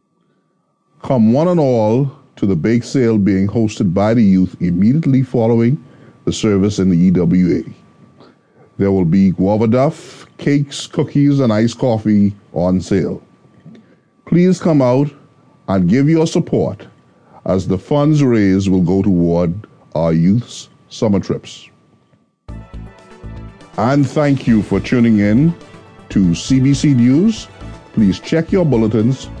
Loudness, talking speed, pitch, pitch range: -14 LUFS, 130 wpm, 115 Hz, 100-145 Hz